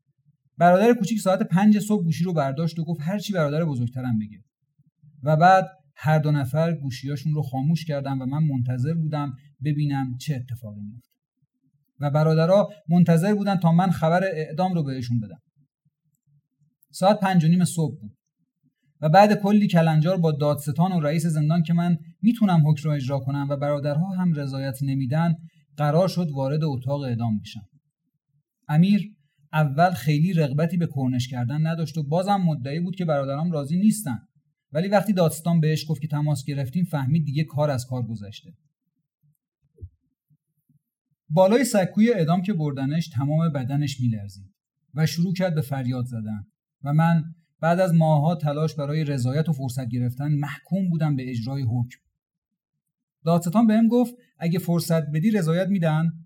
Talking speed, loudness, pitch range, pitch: 155 wpm, -23 LUFS, 140-170 Hz, 155 Hz